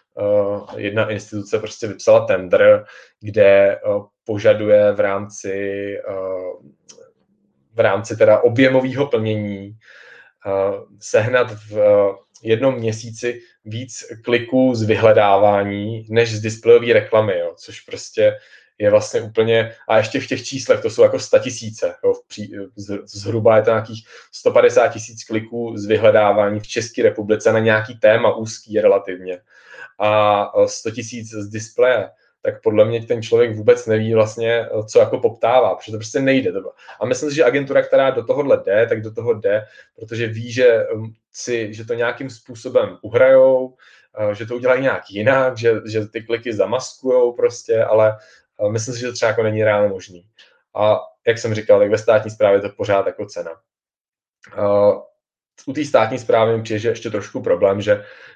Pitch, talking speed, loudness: 115 Hz, 155 wpm, -17 LUFS